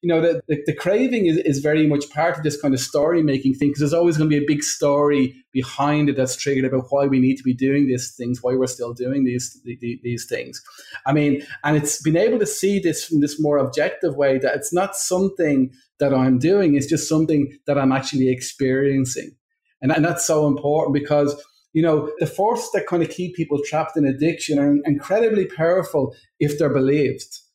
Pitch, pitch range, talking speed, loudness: 145 Hz, 135-165 Hz, 220 wpm, -20 LUFS